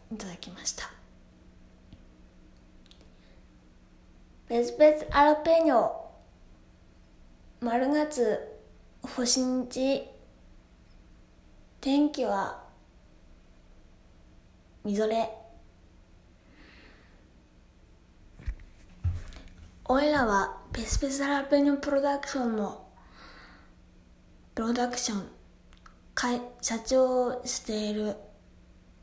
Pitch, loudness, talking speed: 210 Hz, -28 LUFS, 130 characters per minute